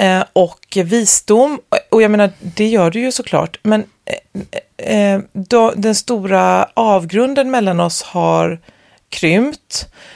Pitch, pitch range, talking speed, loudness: 210 Hz, 190-235 Hz, 110 wpm, -14 LUFS